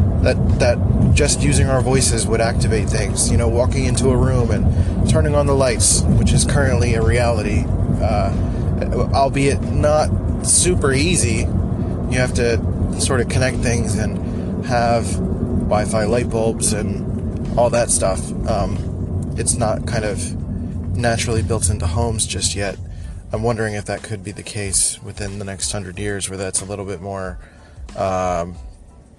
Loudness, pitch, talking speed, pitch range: -18 LUFS, 100 Hz, 160 wpm, 90-115 Hz